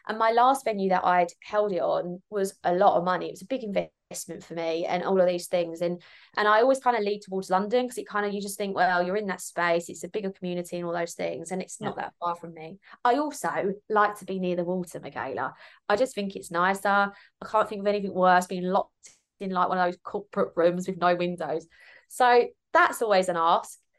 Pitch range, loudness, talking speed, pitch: 175-210 Hz, -26 LUFS, 250 wpm, 185 Hz